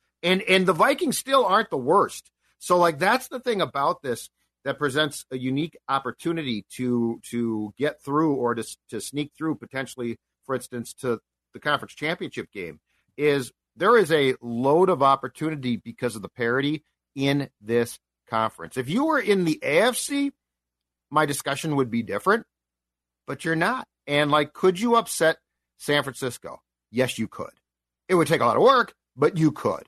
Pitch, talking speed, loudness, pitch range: 140 Hz, 170 wpm, -24 LUFS, 120-160 Hz